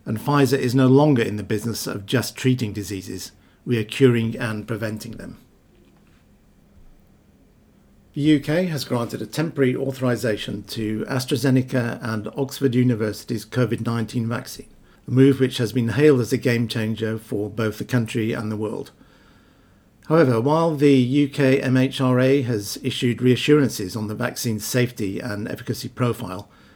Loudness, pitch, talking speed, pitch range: -21 LUFS, 120 Hz, 145 wpm, 110-130 Hz